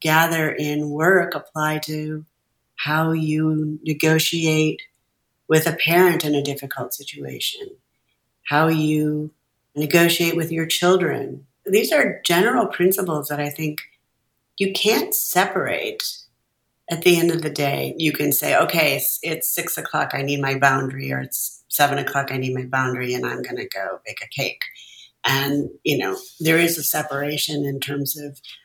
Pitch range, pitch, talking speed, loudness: 140-170 Hz, 155 Hz, 155 wpm, -20 LUFS